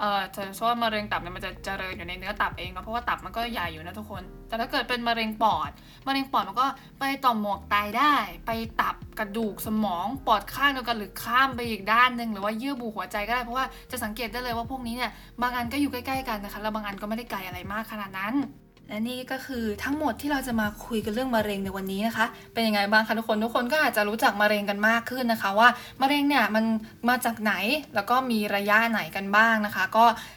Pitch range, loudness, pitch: 210-250 Hz, -26 LUFS, 225 Hz